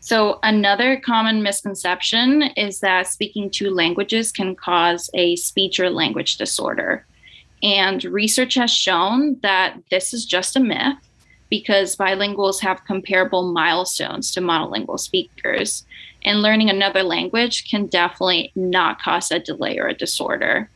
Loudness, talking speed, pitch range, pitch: -19 LUFS, 135 wpm, 185-225 Hz, 200 Hz